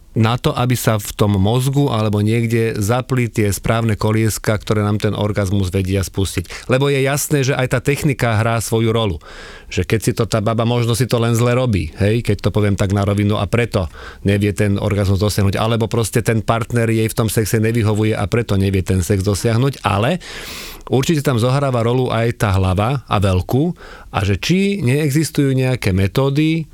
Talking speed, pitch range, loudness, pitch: 190 wpm, 105-125 Hz, -17 LUFS, 115 Hz